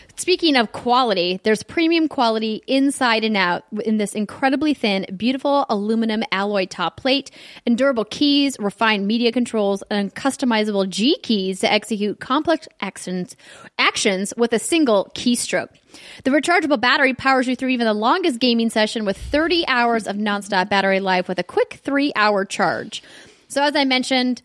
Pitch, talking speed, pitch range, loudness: 230 Hz, 155 wpm, 205-275 Hz, -19 LUFS